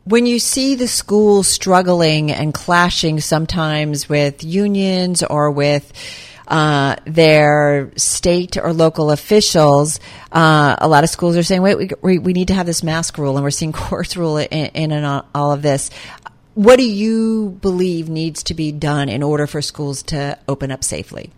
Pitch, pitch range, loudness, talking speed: 155 Hz, 145-180 Hz, -15 LUFS, 175 wpm